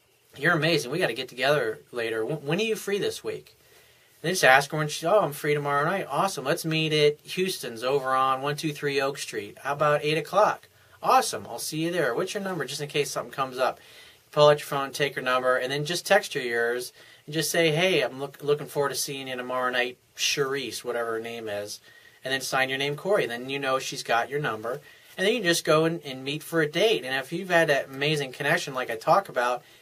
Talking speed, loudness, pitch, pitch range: 240 wpm, -26 LUFS, 145 Hz, 130-160 Hz